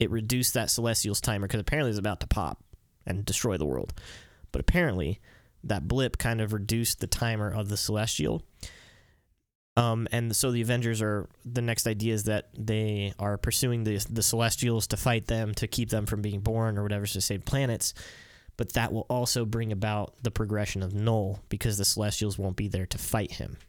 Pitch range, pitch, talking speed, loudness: 105-115 Hz, 110 Hz, 200 wpm, -29 LUFS